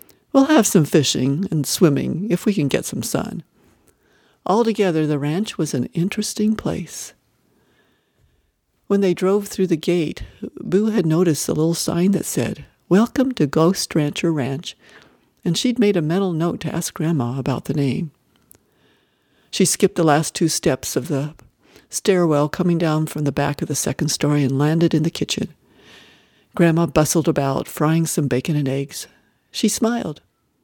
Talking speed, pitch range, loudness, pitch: 165 wpm, 150-190 Hz, -19 LUFS, 165 Hz